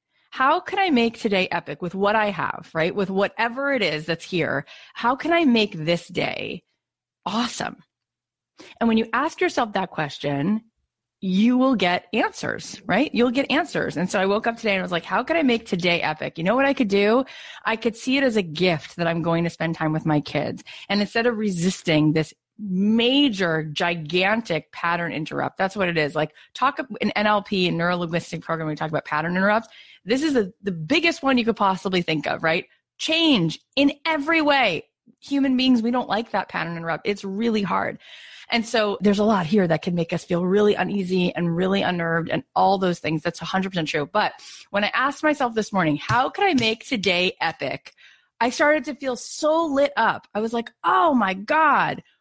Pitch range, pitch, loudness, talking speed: 170-245 Hz, 200 Hz, -22 LUFS, 205 wpm